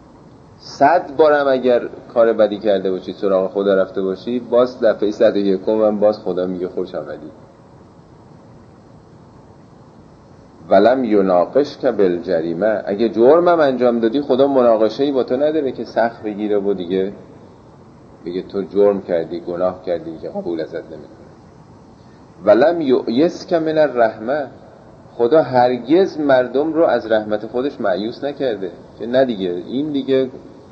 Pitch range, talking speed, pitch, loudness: 100-135 Hz, 135 wpm, 115 Hz, -17 LUFS